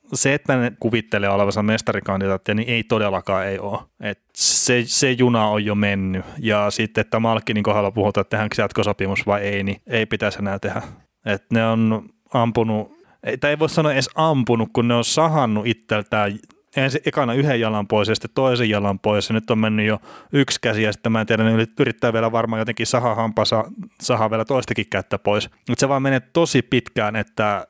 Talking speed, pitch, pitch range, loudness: 195 wpm, 110 Hz, 105-125 Hz, -20 LUFS